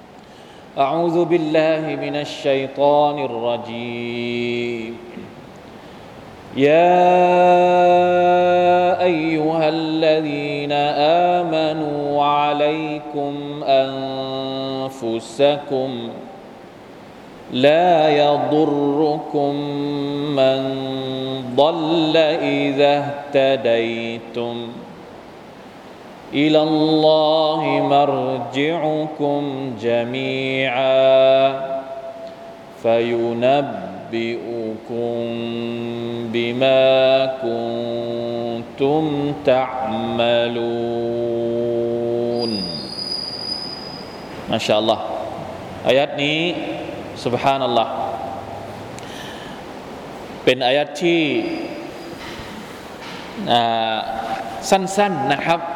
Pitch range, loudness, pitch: 120-155 Hz, -19 LUFS, 135 Hz